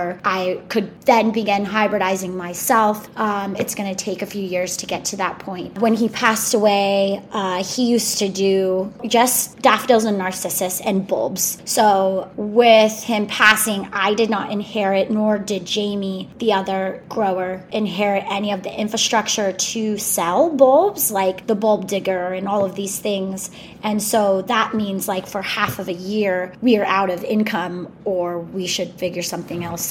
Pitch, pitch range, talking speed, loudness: 200 Hz, 190-215 Hz, 175 wpm, -19 LUFS